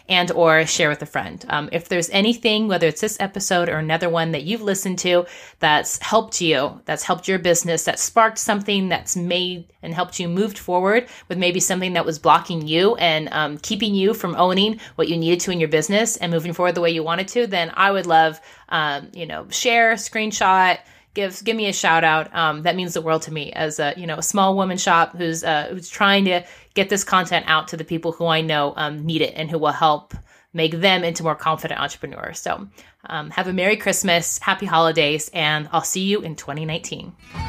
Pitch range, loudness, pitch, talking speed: 160-195 Hz, -19 LUFS, 175 Hz, 220 wpm